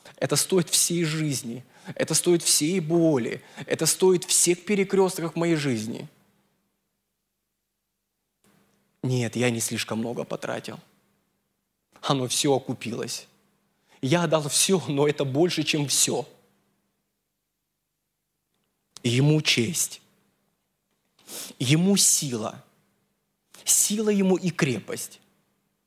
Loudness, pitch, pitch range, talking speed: -23 LUFS, 155 Hz, 130-175 Hz, 90 wpm